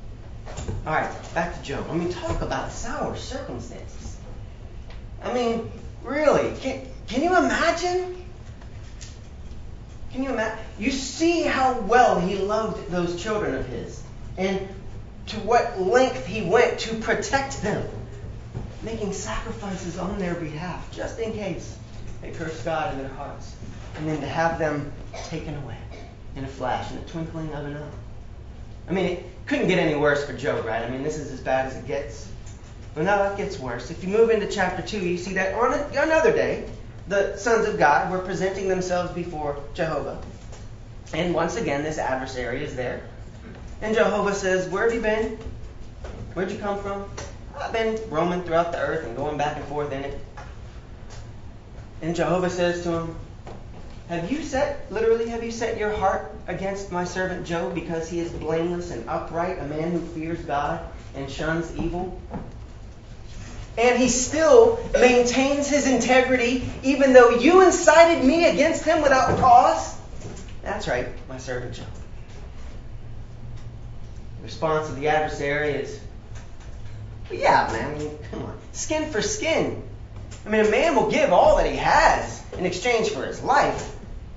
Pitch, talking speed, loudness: 165 Hz, 160 wpm, -23 LUFS